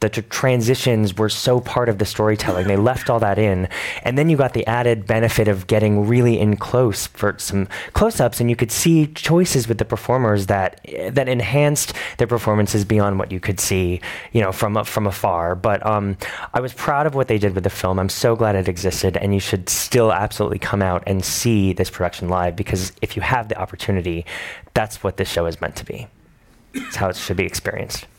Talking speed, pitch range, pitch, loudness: 215 wpm, 95-120 Hz, 105 Hz, -19 LUFS